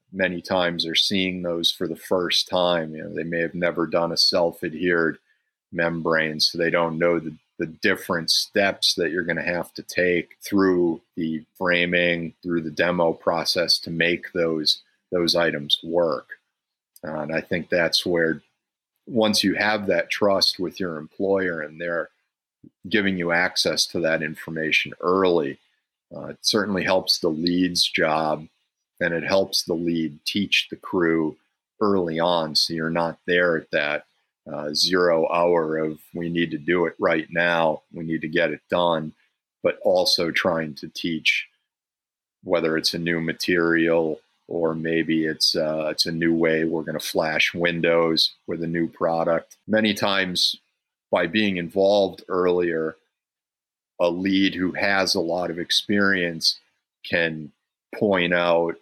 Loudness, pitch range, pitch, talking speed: -22 LUFS, 80-90 Hz, 85 Hz, 160 wpm